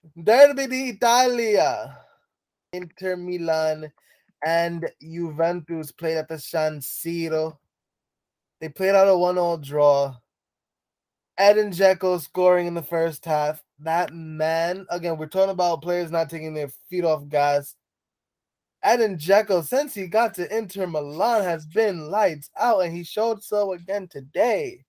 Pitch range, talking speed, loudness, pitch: 160-195 Hz, 135 wpm, -23 LUFS, 170 Hz